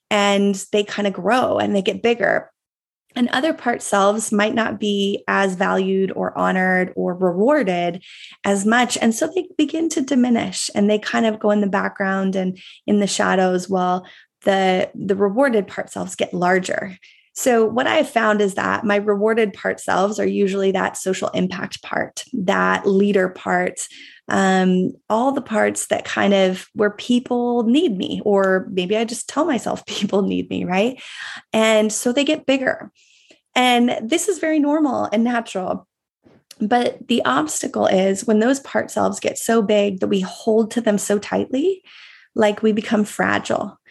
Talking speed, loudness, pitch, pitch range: 170 wpm, -19 LUFS, 210 Hz, 195-240 Hz